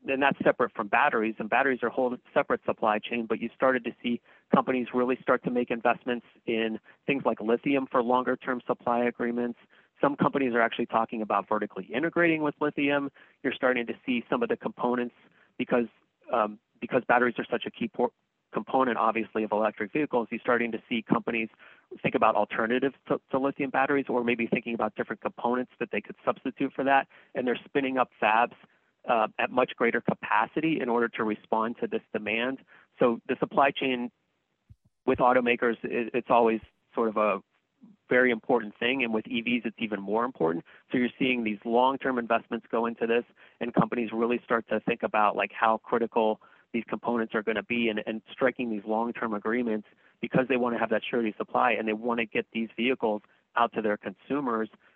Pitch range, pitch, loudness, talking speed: 110-125 Hz, 120 Hz, -28 LUFS, 195 wpm